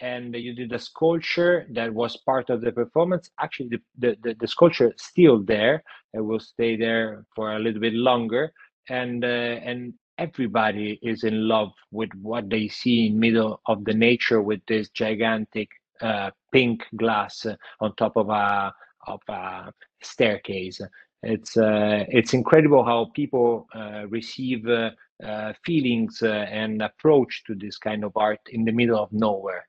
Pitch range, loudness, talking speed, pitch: 110-120 Hz, -23 LUFS, 165 wpm, 115 Hz